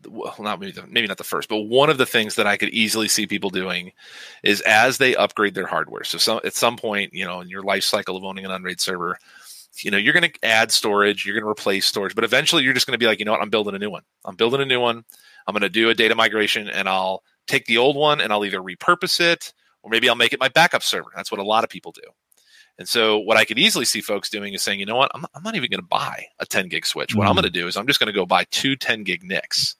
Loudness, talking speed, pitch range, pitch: -19 LUFS, 300 wpm, 100-125 Hz, 105 Hz